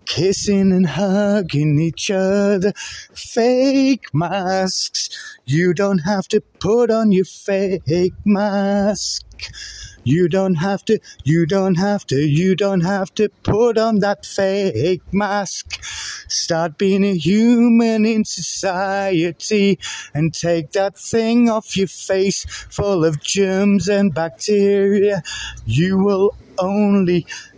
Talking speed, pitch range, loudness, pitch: 120 wpm, 180-205 Hz, -17 LUFS, 195 Hz